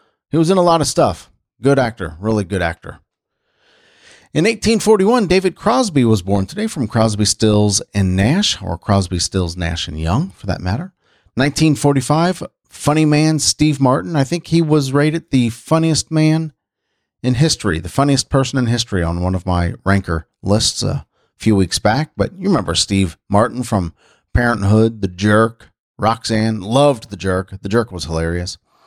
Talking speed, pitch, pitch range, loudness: 165 wpm, 110 Hz, 95-150 Hz, -16 LUFS